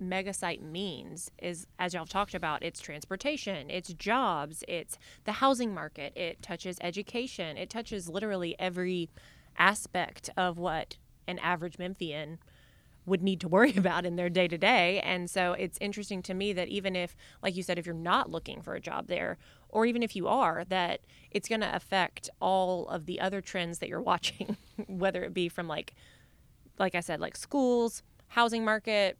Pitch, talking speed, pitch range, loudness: 185 Hz, 185 wpm, 175-200 Hz, -32 LUFS